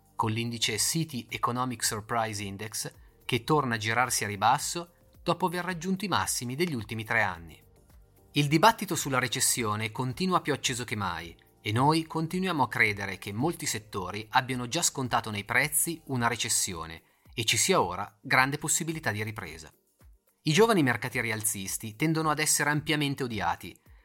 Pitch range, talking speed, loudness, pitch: 110-155 Hz, 155 wpm, -28 LUFS, 125 Hz